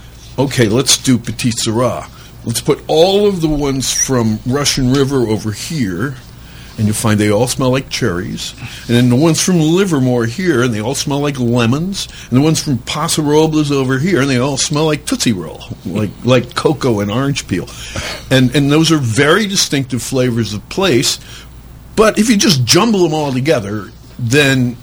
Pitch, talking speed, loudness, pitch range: 130 Hz, 185 wpm, -14 LUFS, 120-150 Hz